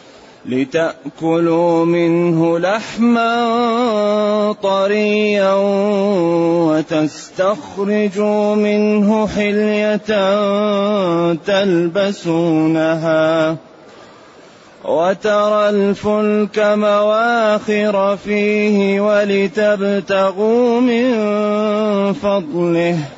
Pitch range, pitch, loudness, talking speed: 170-210 Hz, 200 Hz, -15 LUFS, 40 wpm